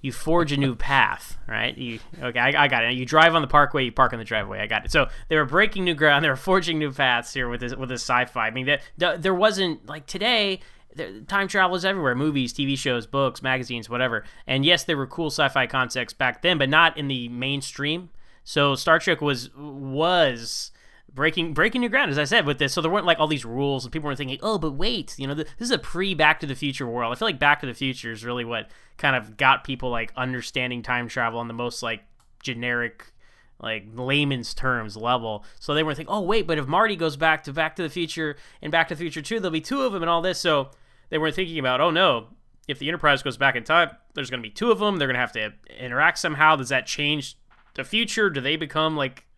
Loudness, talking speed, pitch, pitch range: -23 LUFS, 255 wpm, 145 Hz, 125-165 Hz